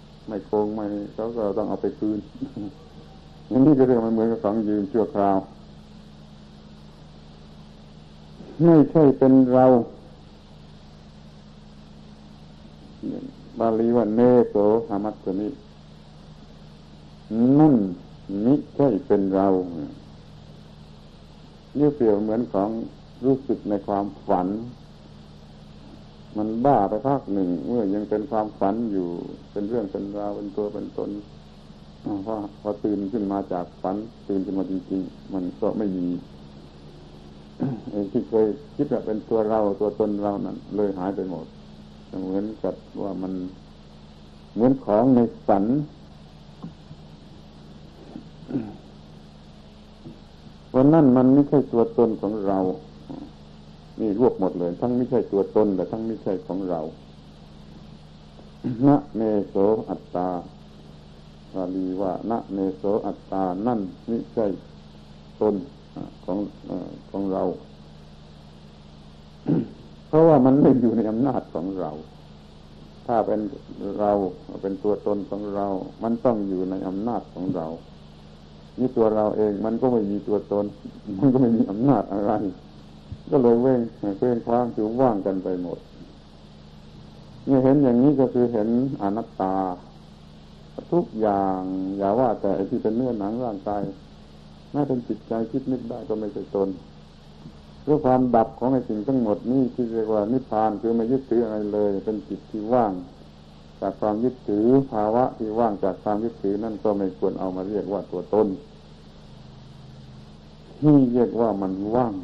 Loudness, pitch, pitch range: -23 LUFS, 95 Hz, 75-110 Hz